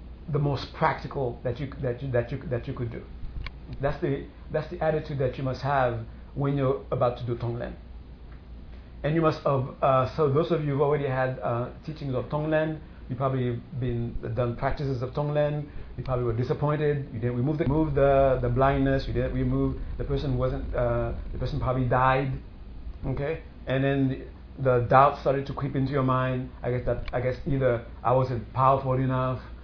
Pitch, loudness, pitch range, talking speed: 130 Hz, -27 LUFS, 120-140 Hz, 195 wpm